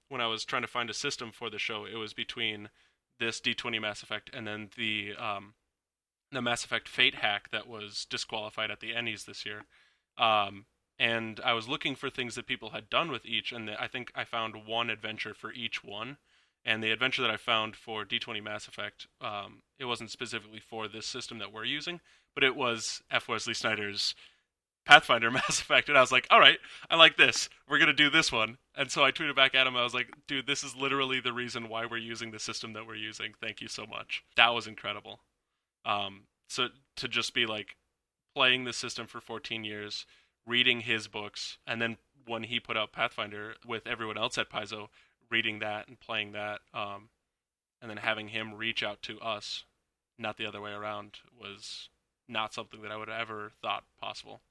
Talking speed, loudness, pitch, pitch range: 210 wpm, -30 LUFS, 115 Hz, 105-120 Hz